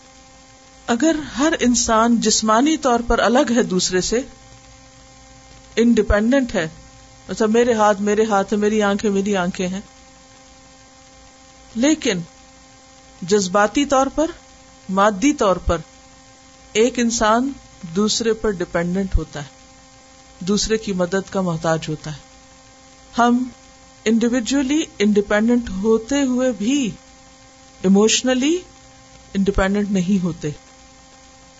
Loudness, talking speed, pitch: -18 LUFS, 100 wpm, 195 Hz